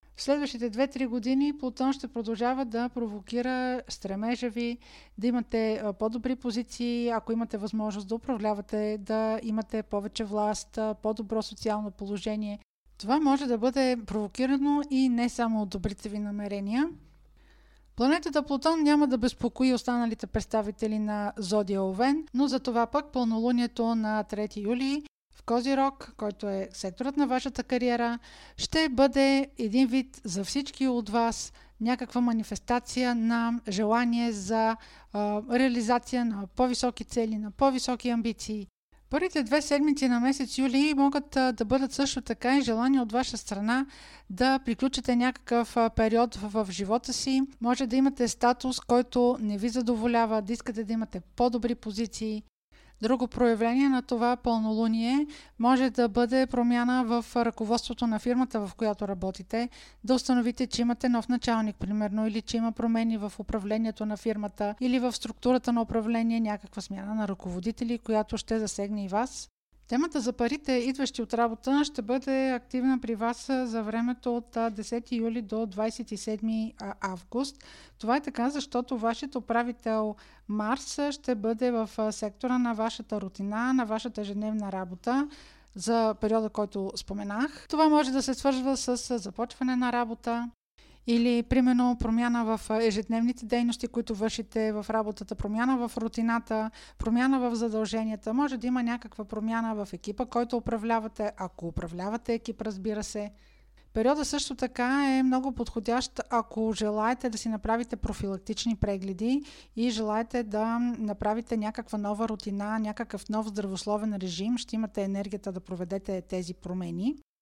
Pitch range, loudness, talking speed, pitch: 215-255 Hz, -29 LUFS, 145 wpm, 235 Hz